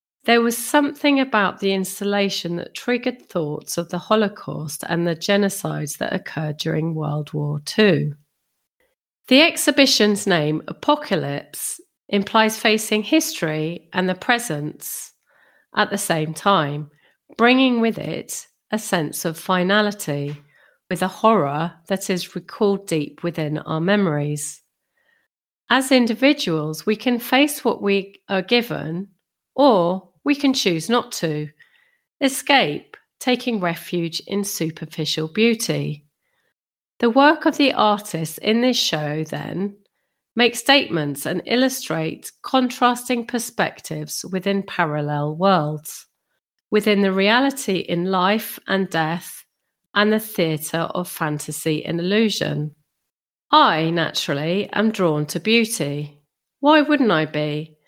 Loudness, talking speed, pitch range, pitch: -20 LUFS, 120 wpm, 160-235 Hz, 195 Hz